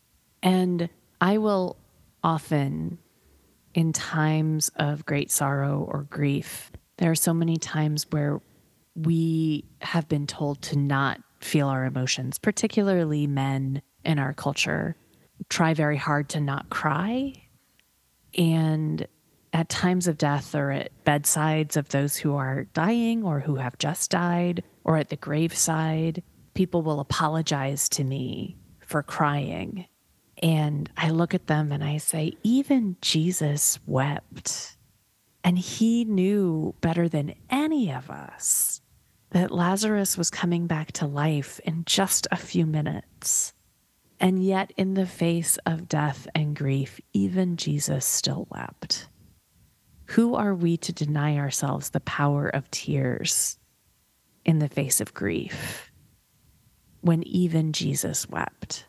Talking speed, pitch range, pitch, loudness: 130 wpm, 145-175 Hz, 155 Hz, -25 LUFS